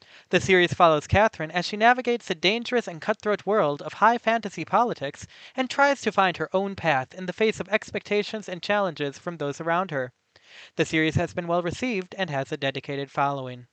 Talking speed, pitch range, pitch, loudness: 195 wpm, 155-210 Hz, 180 Hz, -25 LUFS